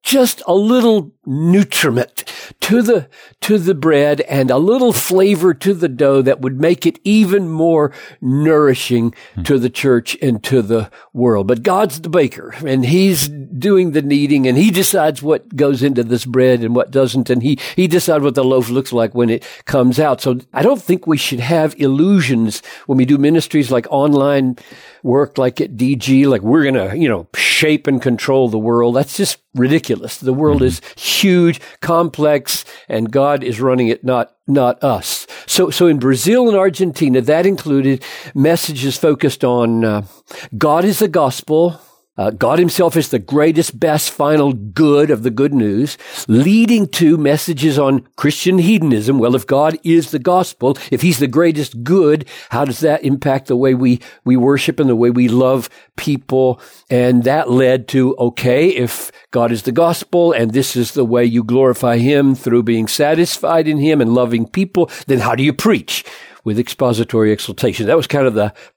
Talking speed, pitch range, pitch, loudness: 180 wpm, 125-165 Hz, 140 Hz, -14 LUFS